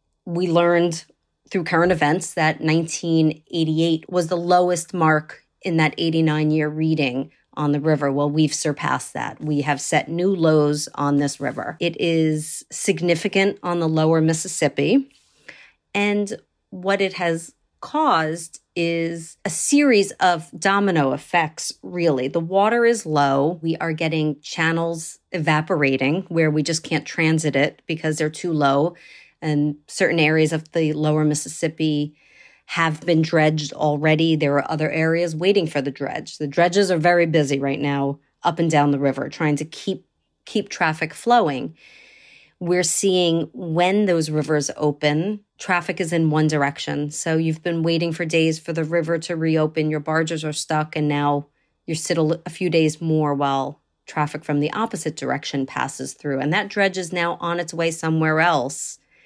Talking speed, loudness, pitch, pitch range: 160 wpm, -21 LUFS, 160 Hz, 150-175 Hz